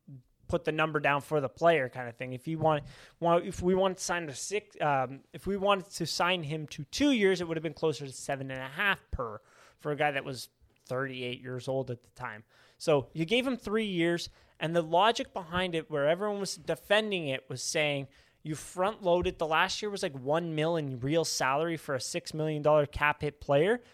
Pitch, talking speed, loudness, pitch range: 155 Hz, 230 wpm, -30 LUFS, 135-175 Hz